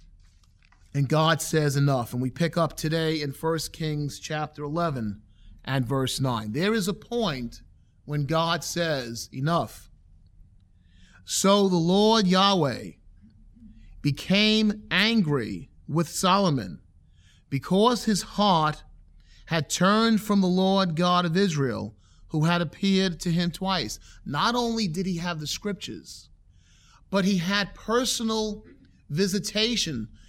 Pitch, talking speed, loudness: 160 Hz, 125 wpm, -25 LUFS